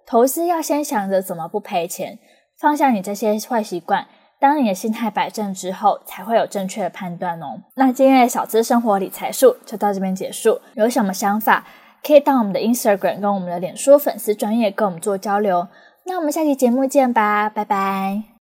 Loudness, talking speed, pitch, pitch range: -19 LUFS, 330 characters per minute, 215 Hz, 195-270 Hz